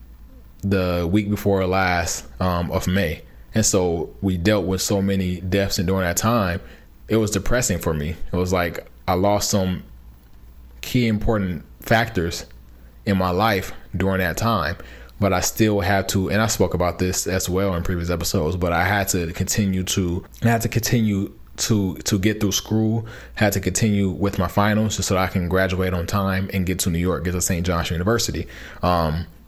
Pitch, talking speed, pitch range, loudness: 95 Hz, 195 wpm, 85-100 Hz, -21 LUFS